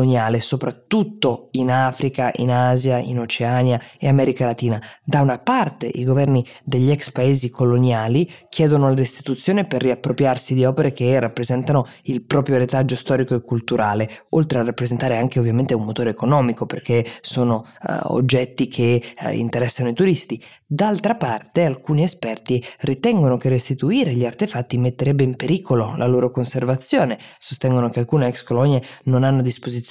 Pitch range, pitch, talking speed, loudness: 120-140 Hz, 130 Hz, 150 wpm, -19 LUFS